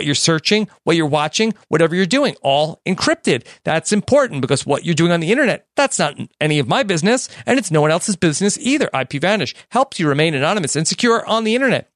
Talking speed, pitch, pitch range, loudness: 210 wpm, 175 Hz, 155-225 Hz, -17 LUFS